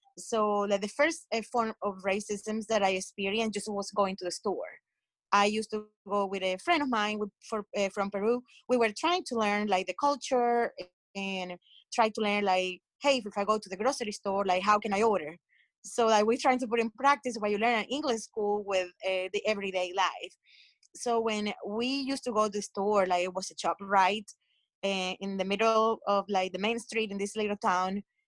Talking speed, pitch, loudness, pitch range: 220 wpm, 210 Hz, -30 LUFS, 195-225 Hz